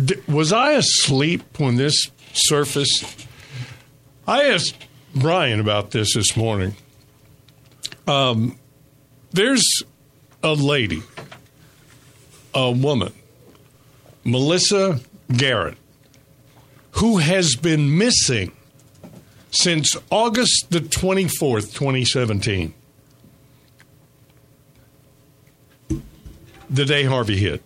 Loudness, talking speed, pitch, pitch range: -19 LUFS, 75 wpm, 135 Hz, 125-145 Hz